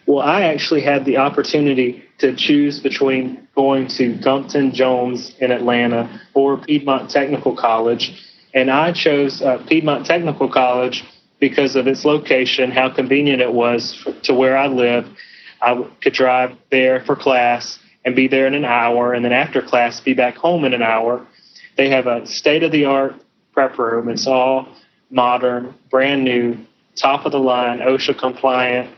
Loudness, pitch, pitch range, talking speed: -16 LUFS, 130 Hz, 125-135 Hz, 165 wpm